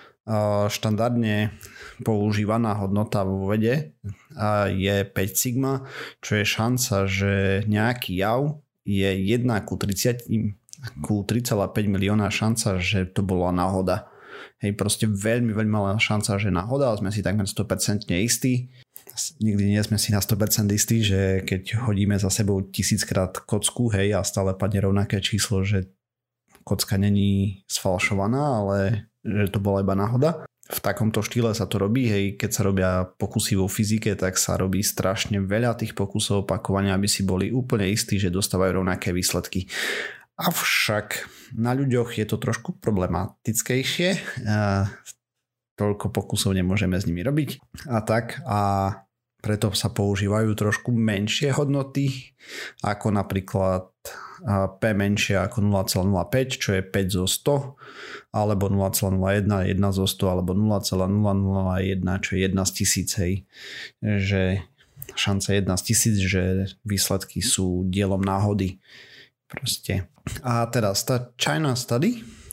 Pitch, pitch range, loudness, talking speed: 105 Hz, 95-115 Hz, -24 LUFS, 135 wpm